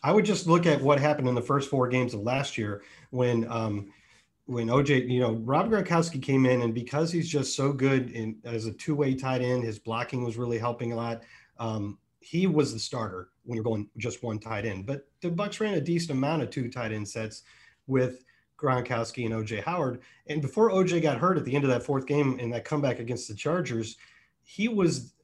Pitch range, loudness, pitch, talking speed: 115-150 Hz, -28 LUFS, 125 Hz, 220 wpm